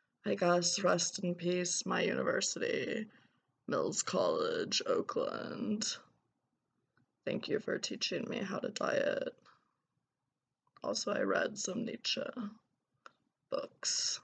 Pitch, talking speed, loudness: 240 Hz, 100 wpm, -35 LUFS